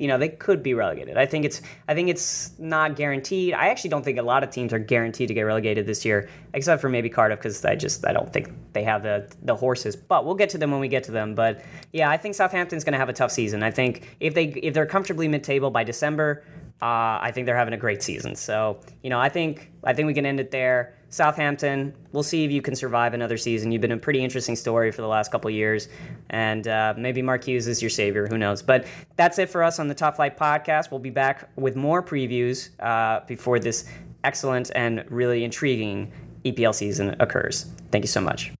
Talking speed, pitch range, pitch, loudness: 240 wpm, 115-150 Hz, 130 Hz, -24 LUFS